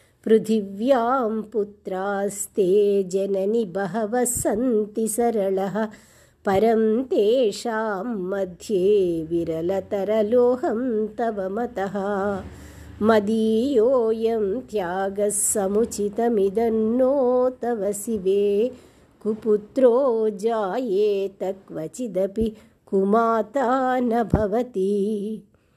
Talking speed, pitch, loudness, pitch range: 55 wpm, 215 Hz, -22 LUFS, 200-230 Hz